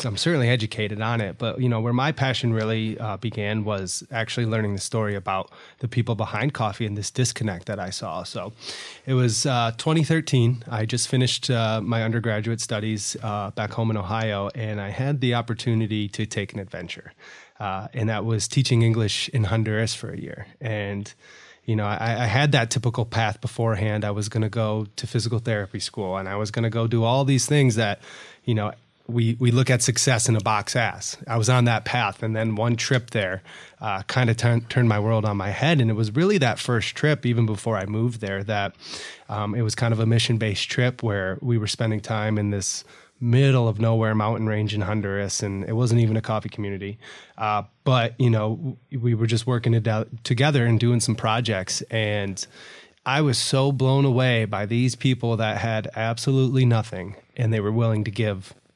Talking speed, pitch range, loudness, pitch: 210 wpm, 105-125 Hz, -23 LUFS, 115 Hz